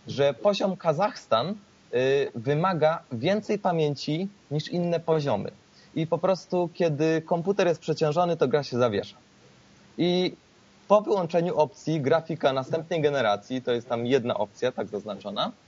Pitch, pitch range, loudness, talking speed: 160 Hz, 140-180 Hz, -26 LUFS, 135 wpm